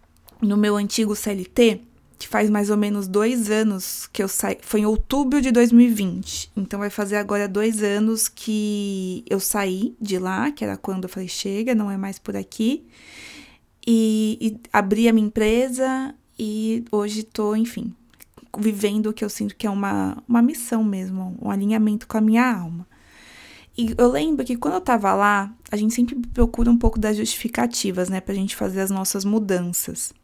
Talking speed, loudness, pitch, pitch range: 180 wpm, -22 LUFS, 215 Hz, 200-230 Hz